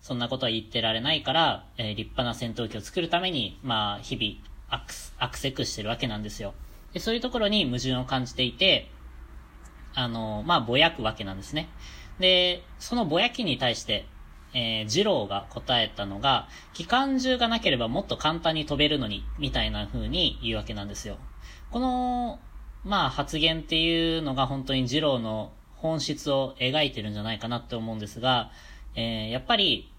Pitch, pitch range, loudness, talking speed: 120 Hz, 105-155 Hz, -26 LUFS, 360 characters per minute